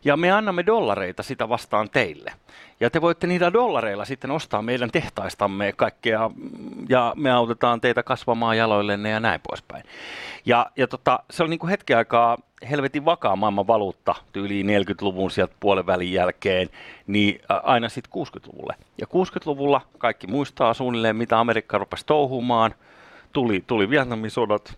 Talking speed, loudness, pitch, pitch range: 150 wpm, -22 LUFS, 120 Hz, 105-145 Hz